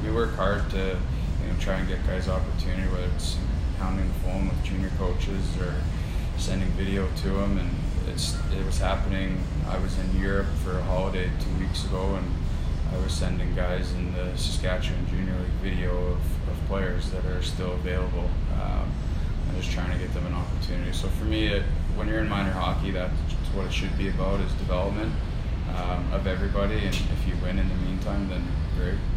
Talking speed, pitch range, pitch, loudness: 195 wpm, 80-95 Hz, 90 Hz, -28 LUFS